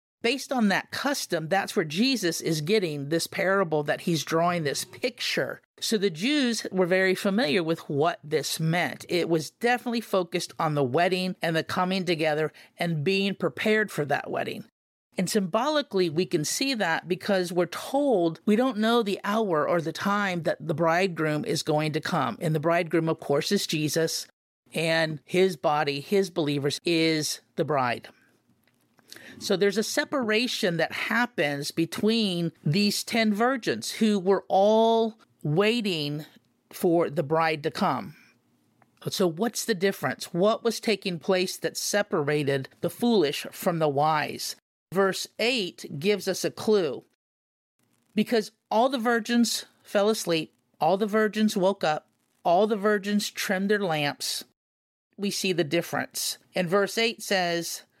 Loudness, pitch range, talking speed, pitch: -26 LUFS, 165-215 Hz, 150 wpm, 185 Hz